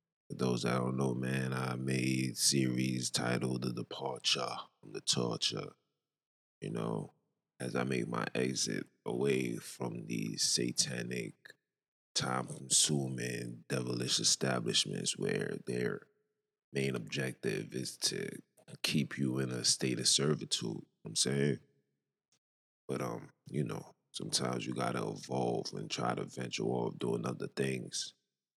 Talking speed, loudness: 130 wpm, -34 LUFS